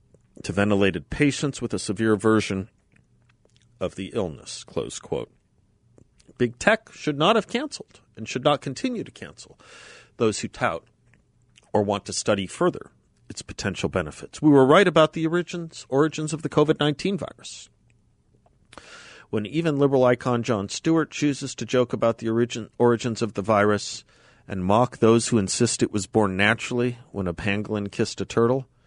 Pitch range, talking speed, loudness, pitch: 105-140 Hz, 160 wpm, -23 LUFS, 120 Hz